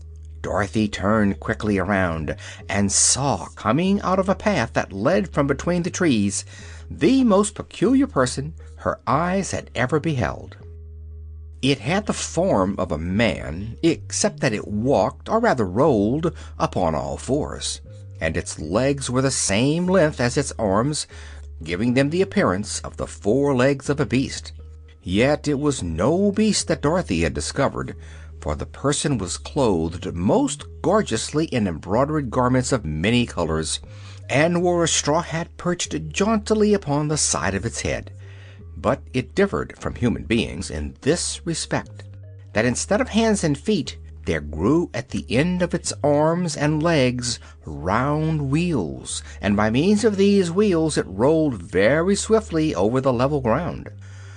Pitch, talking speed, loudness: 110 Hz, 155 wpm, -21 LUFS